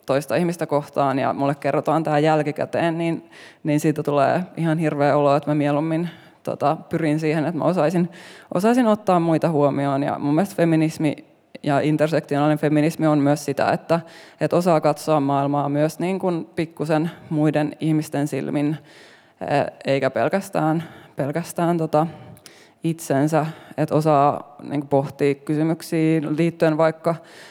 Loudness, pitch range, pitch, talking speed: -21 LUFS, 145-165 Hz, 155 Hz, 135 wpm